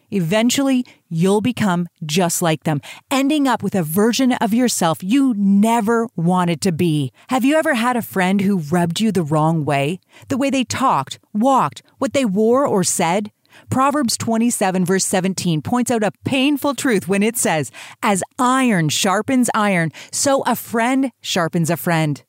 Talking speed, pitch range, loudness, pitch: 165 wpm, 175-250 Hz, -18 LUFS, 205 Hz